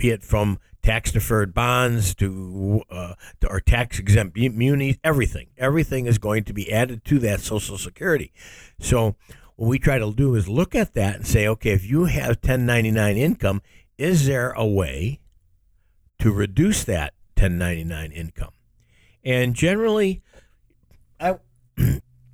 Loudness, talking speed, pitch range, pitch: -22 LUFS, 145 wpm, 95-130 Hz, 110 Hz